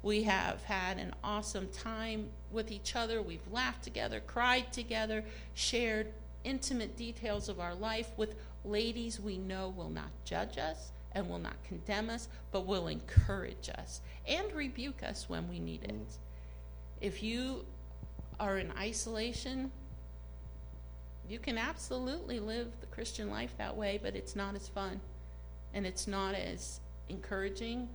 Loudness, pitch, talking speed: -38 LUFS, 200 Hz, 145 wpm